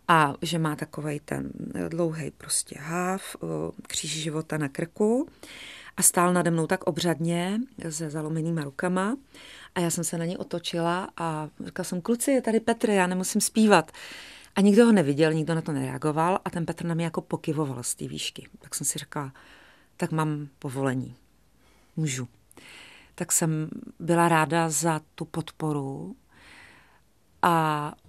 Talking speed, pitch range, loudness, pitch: 155 wpm, 155-180 Hz, -26 LUFS, 165 Hz